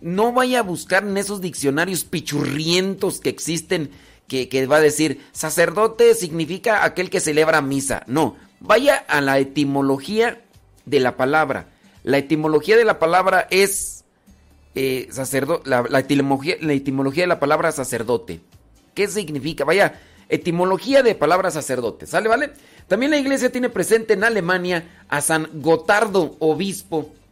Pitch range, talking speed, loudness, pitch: 140-190 Hz, 145 wpm, -19 LUFS, 160 Hz